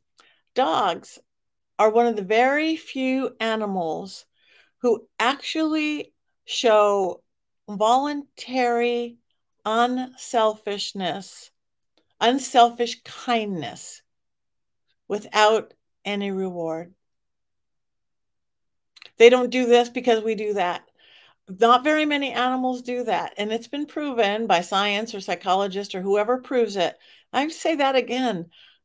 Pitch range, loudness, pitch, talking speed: 205-255 Hz, -22 LUFS, 235 Hz, 100 wpm